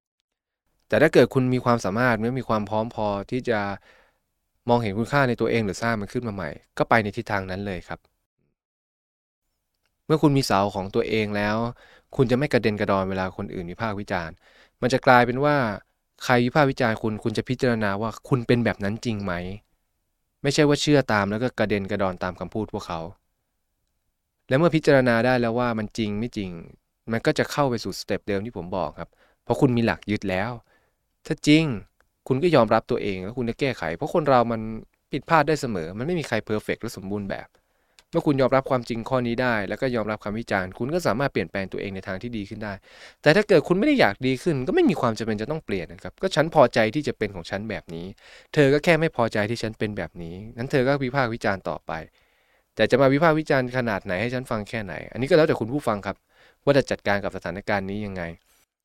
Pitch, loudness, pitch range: 115 Hz, -24 LUFS, 100-125 Hz